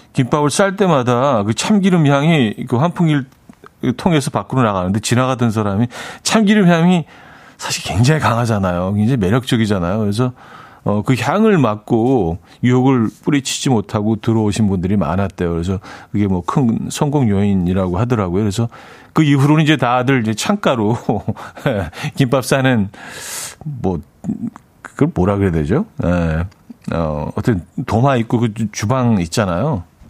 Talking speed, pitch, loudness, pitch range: 305 characters per minute, 120 Hz, -16 LUFS, 100-140 Hz